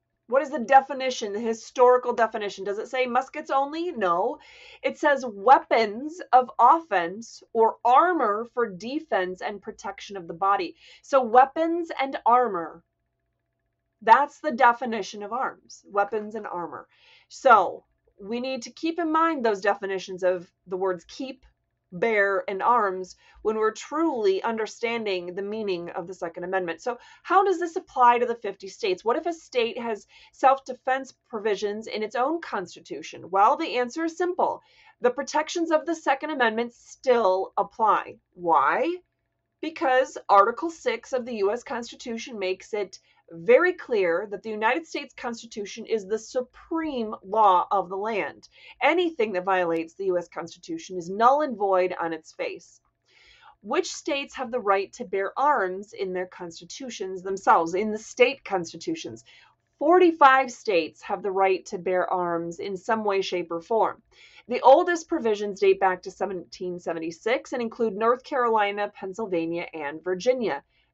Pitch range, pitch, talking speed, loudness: 195-285 Hz, 230 Hz, 150 wpm, -25 LUFS